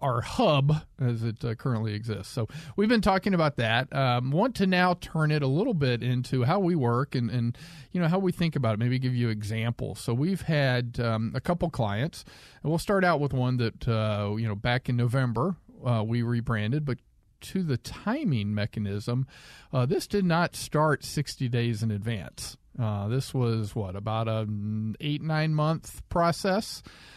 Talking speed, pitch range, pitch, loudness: 190 wpm, 115-155 Hz, 130 Hz, -28 LUFS